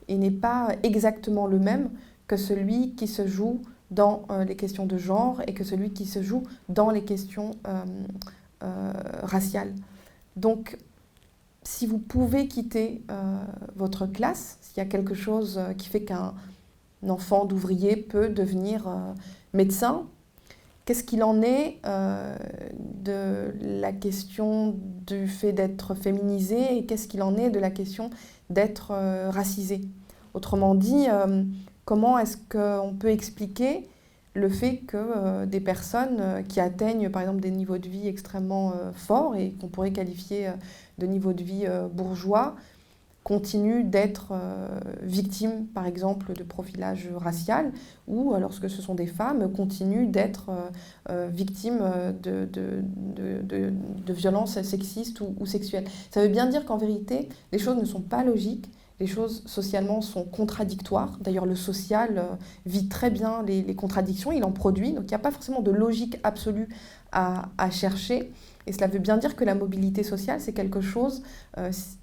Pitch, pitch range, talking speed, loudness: 200 Hz, 190-220 Hz, 160 wpm, -27 LUFS